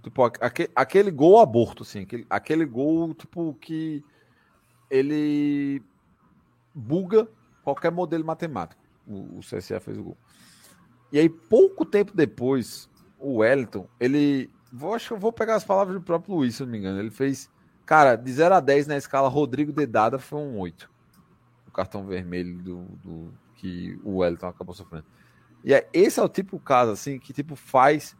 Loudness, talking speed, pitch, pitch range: -23 LUFS, 170 wpm, 140 Hz, 115-160 Hz